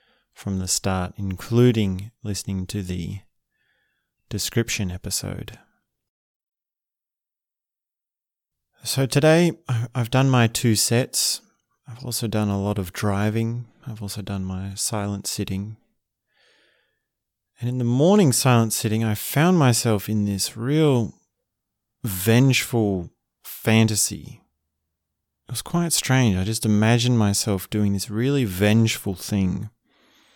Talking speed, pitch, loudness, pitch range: 110 wpm, 110 Hz, -22 LUFS, 100-125 Hz